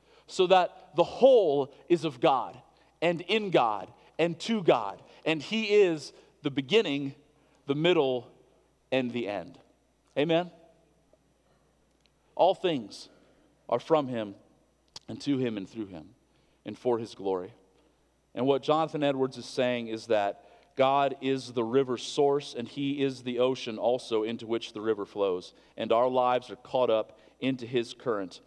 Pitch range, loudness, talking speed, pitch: 120-160 Hz, -28 LUFS, 150 wpm, 135 Hz